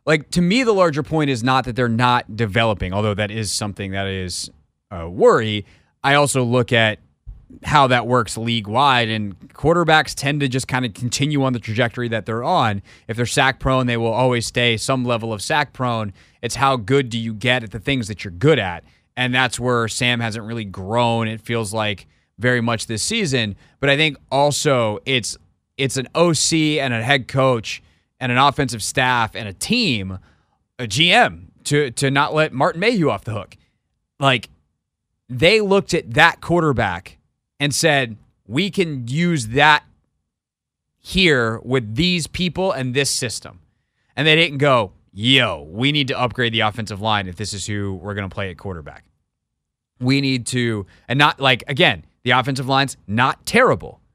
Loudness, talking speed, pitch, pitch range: -18 LUFS, 185 wpm, 125 Hz, 110-140 Hz